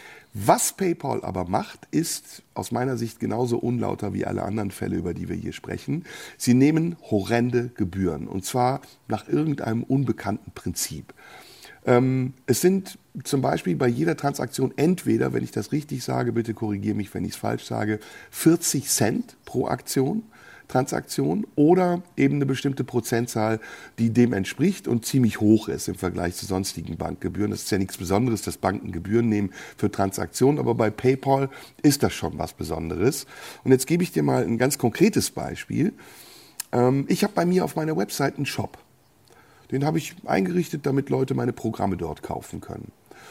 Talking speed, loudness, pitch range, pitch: 170 wpm, -24 LUFS, 105-140 Hz, 120 Hz